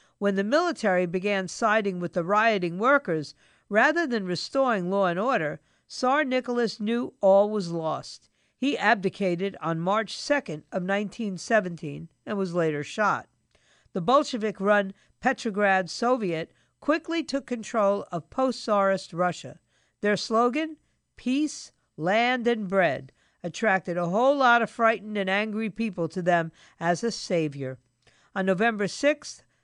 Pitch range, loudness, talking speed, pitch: 180-240 Hz, -26 LUFS, 130 wpm, 205 Hz